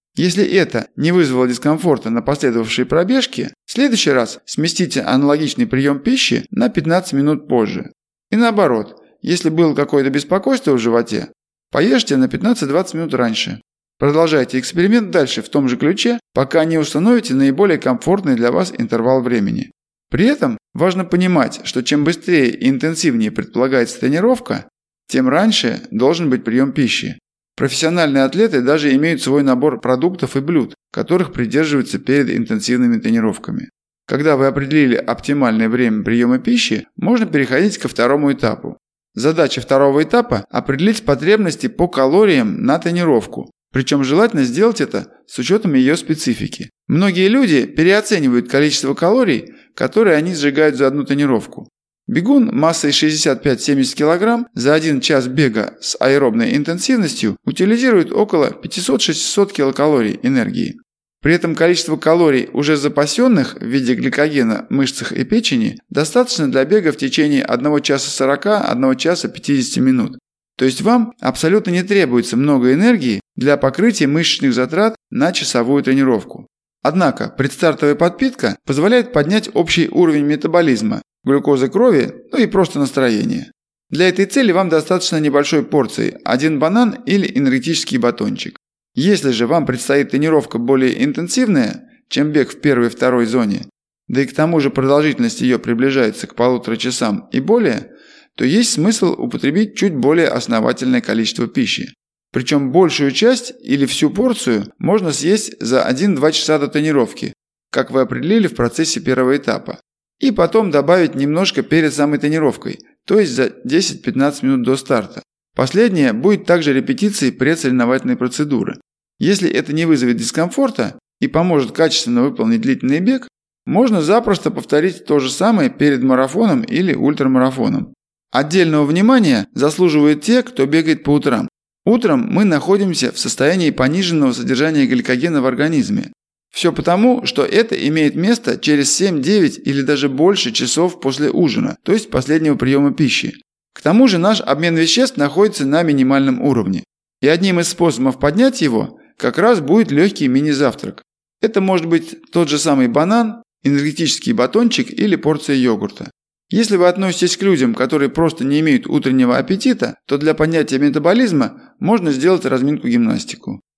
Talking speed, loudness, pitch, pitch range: 140 wpm, -15 LUFS, 160 Hz, 140-215 Hz